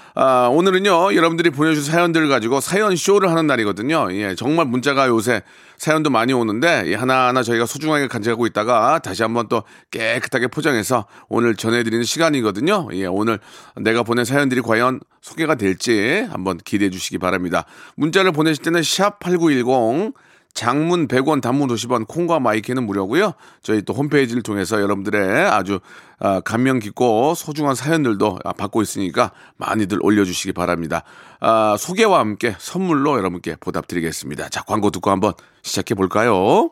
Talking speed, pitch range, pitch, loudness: 375 characters per minute, 105-155 Hz, 125 Hz, -18 LUFS